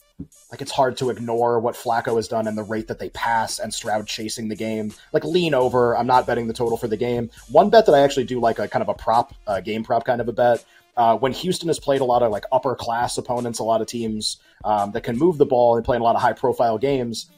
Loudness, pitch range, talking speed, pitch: -21 LUFS, 110-125 Hz, 280 wpm, 120 Hz